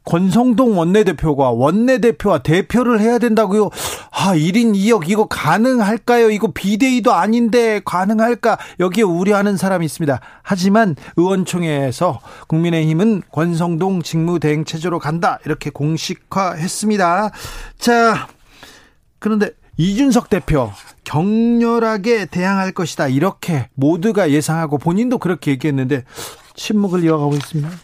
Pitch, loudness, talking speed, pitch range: 190 Hz, -16 LUFS, 315 characters per minute, 160-220 Hz